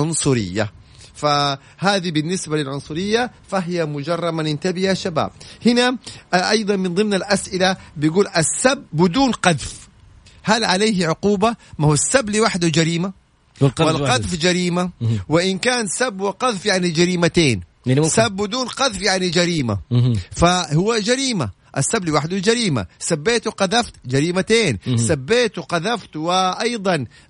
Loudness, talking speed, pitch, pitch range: -19 LUFS, 110 wpm, 180 Hz, 145-205 Hz